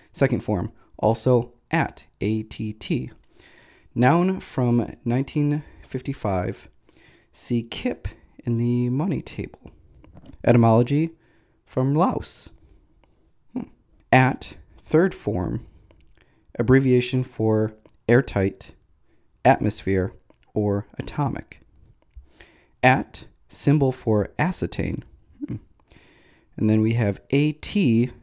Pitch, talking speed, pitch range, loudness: 120 Hz, 85 wpm, 110-130 Hz, -23 LUFS